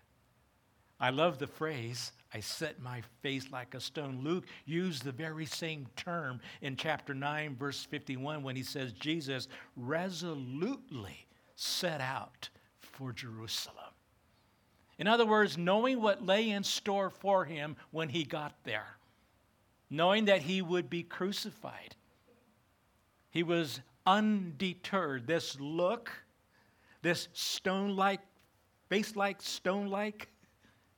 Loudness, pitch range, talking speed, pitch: -35 LUFS, 125-185 Hz, 120 wpm, 155 Hz